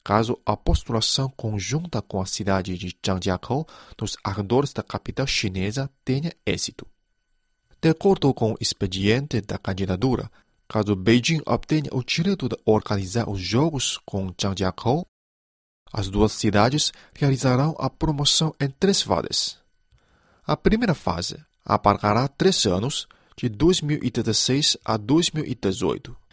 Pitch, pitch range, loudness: 115 Hz, 100-140 Hz, -23 LUFS